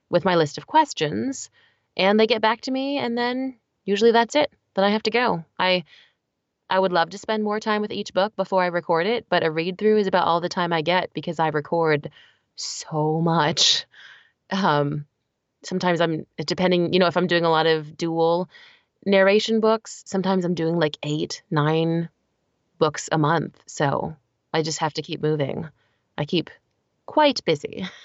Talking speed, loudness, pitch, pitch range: 185 wpm, -22 LUFS, 175 Hz, 160-210 Hz